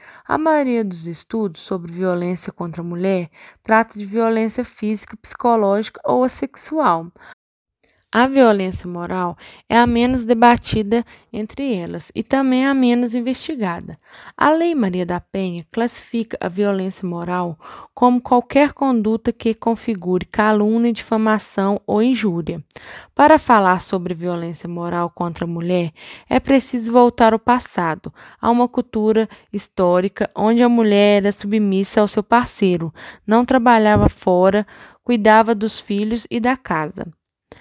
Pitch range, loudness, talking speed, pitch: 185-240 Hz, -18 LUFS, 130 wpm, 215 Hz